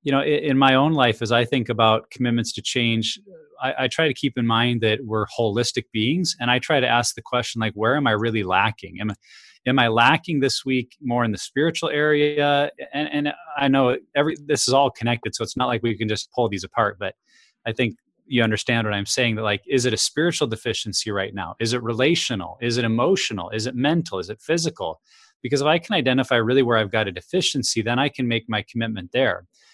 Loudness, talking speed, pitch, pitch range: -21 LUFS, 230 wpm, 120 Hz, 110-140 Hz